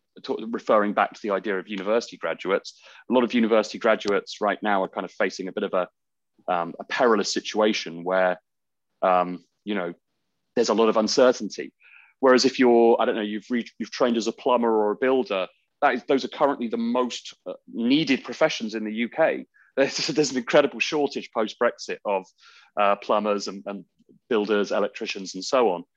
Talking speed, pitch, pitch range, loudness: 185 wpm, 115 Hz, 105-130 Hz, -24 LUFS